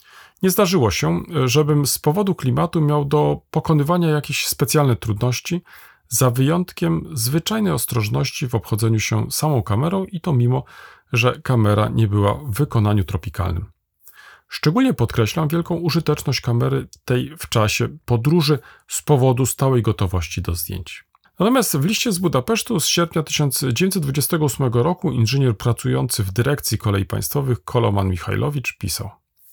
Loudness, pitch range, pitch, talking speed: -19 LUFS, 115-160 Hz, 135 Hz, 130 wpm